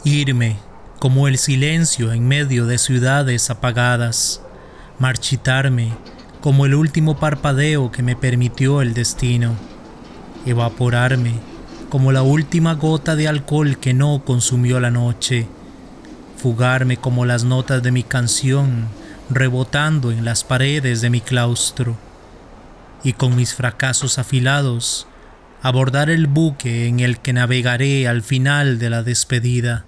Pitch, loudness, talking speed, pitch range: 125 Hz, -17 LUFS, 125 wpm, 120-140 Hz